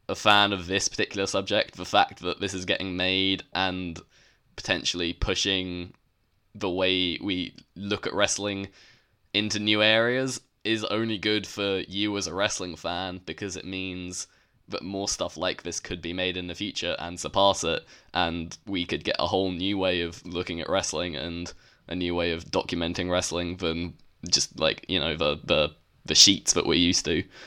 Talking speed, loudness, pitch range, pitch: 180 wpm, -26 LUFS, 85-100 Hz, 95 Hz